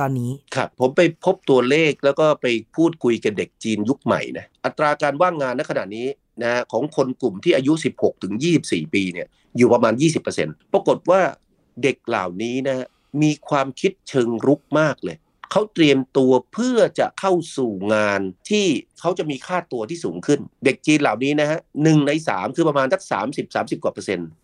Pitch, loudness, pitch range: 140 Hz, -20 LUFS, 125-160 Hz